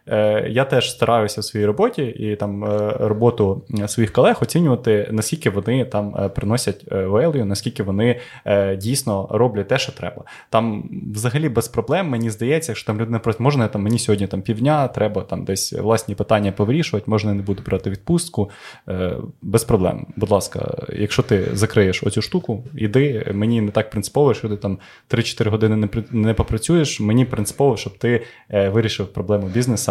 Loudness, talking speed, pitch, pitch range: -20 LUFS, 160 wpm, 110 Hz, 105-120 Hz